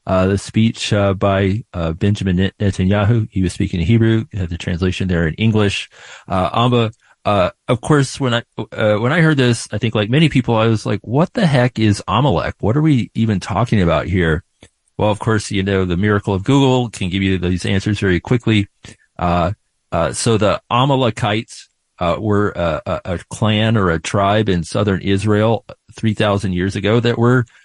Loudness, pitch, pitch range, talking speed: -17 LUFS, 105 Hz, 95-115 Hz, 200 wpm